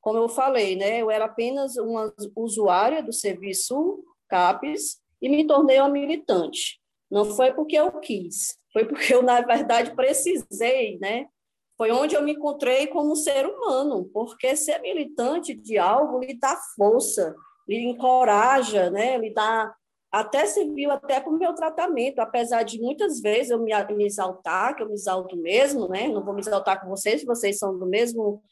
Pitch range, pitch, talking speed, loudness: 210-285 Hz, 240 Hz, 170 wpm, -23 LUFS